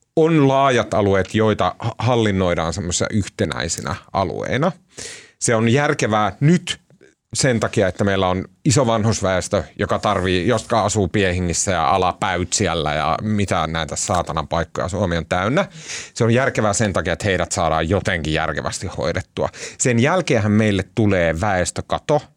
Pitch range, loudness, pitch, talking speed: 90-115 Hz, -19 LUFS, 105 Hz, 135 wpm